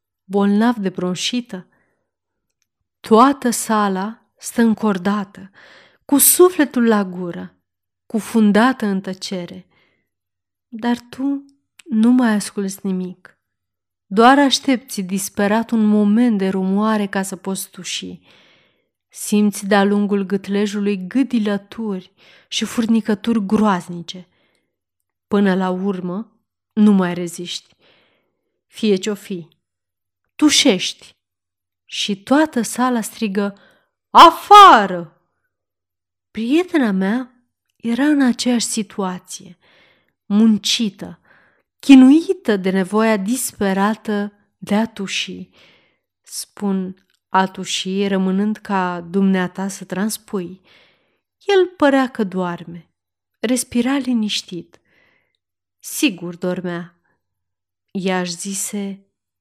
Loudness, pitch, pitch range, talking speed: -17 LUFS, 200 Hz, 180-225 Hz, 85 wpm